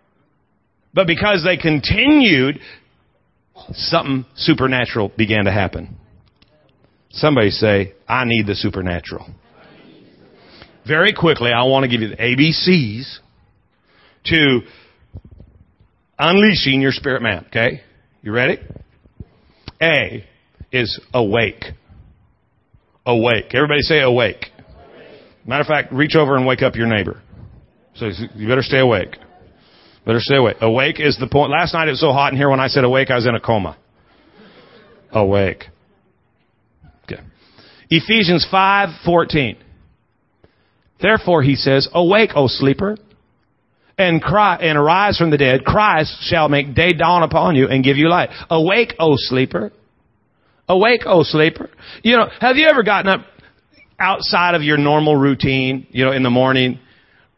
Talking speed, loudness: 135 wpm, -15 LUFS